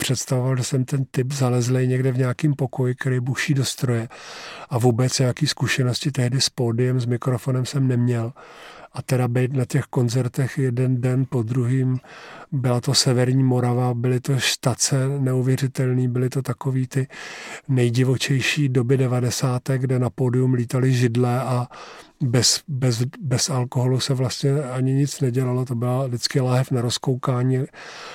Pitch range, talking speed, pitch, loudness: 125-135 Hz, 150 wpm, 130 Hz, -21 LUFS